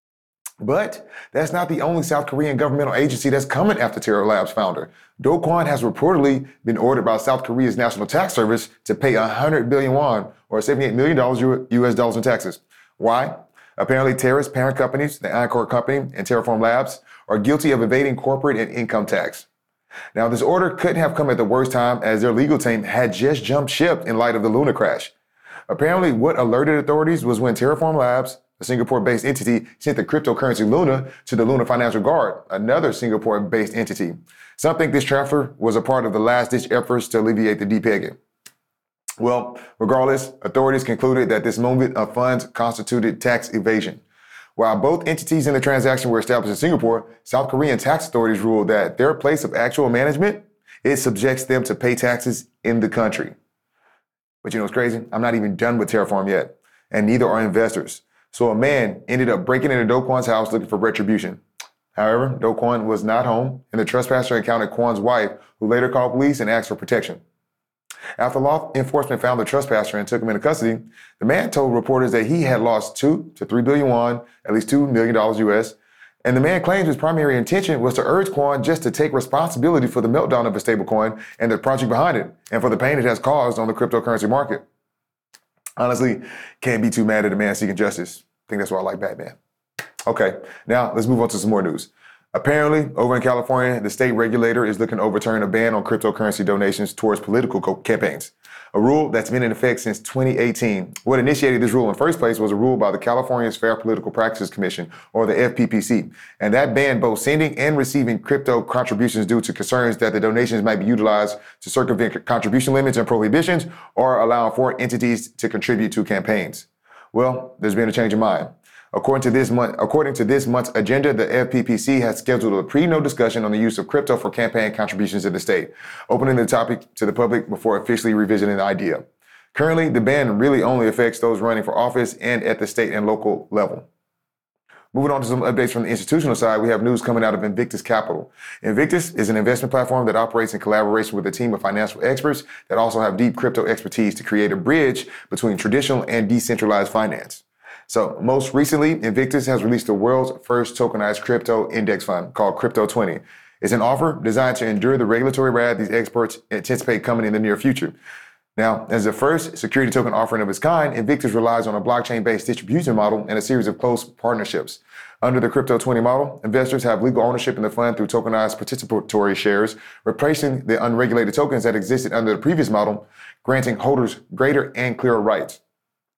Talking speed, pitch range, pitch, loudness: 200 wpm, 110-130 Hz, 120 Hz, -19 LUFS